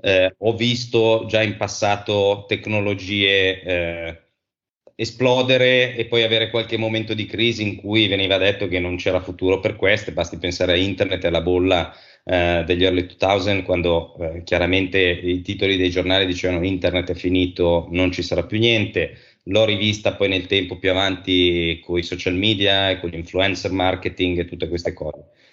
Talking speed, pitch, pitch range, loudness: 170 wpm, 95 Hz, 90-105 Hz, -19 LUFS